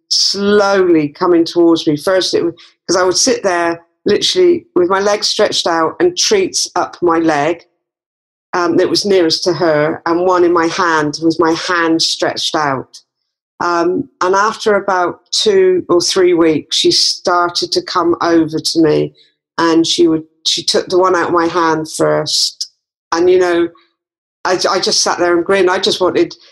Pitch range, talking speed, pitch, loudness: 165-200 Hz, 175 wpm, 175 Hz, -13 LUFS